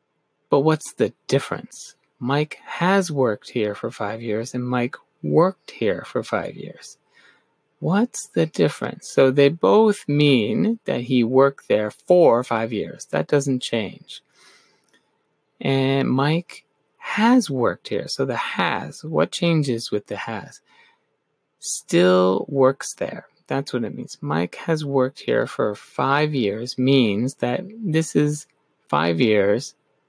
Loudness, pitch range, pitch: -21 LUFS, 120-160 Hz, 135 Hz